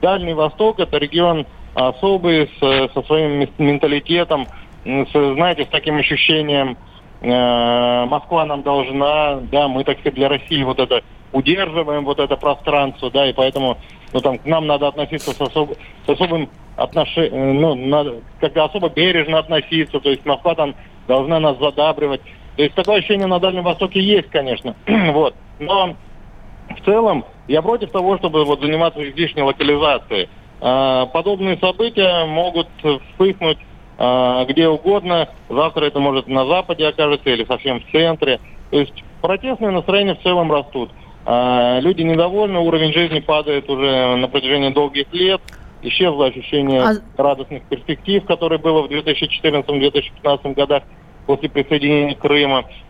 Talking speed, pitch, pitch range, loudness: 140 wpm, 150 Hz, 135-165 Hz, -17 LUFS